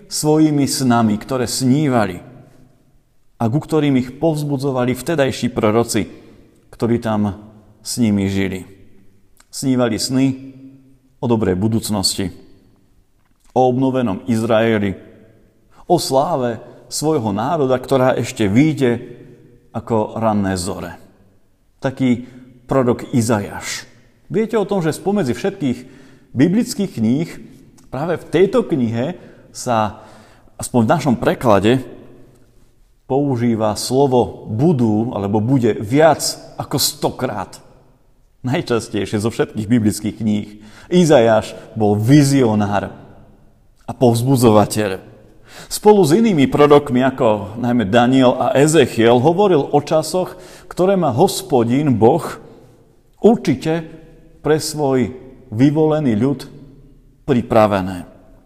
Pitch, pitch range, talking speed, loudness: 125 Hz, 110-140 Hz, 95 wpm, -16 LUFS